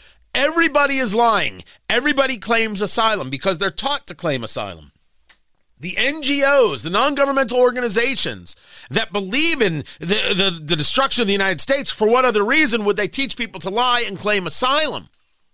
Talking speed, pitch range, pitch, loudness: 160 wpm, 190-270 Hz, 220 Hz, -18 LUFS